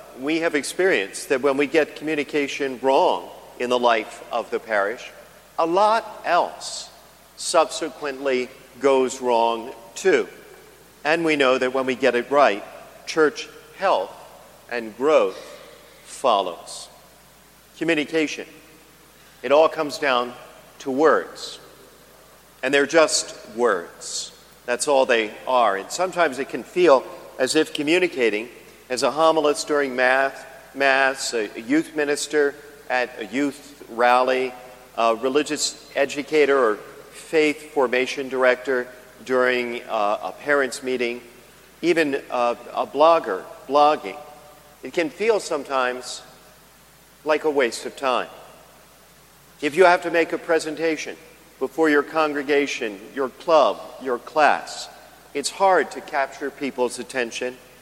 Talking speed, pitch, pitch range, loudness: 120 wpm, 145 Hz, 125-155 Hz, -21 LUFS